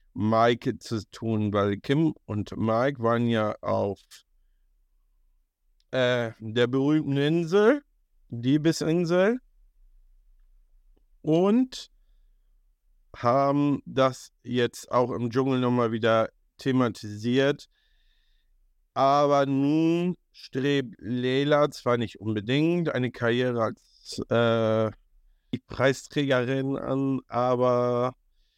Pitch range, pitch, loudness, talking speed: 110-140 Hz, 125 Hz, -25 LUFS, 85 wpm